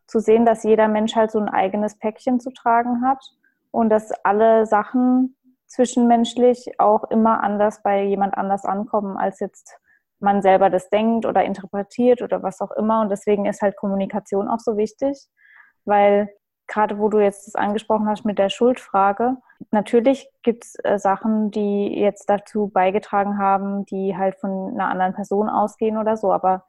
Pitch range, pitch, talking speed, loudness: 200-235 Hz, 210 Hz, 170 wpm, -20 LUFS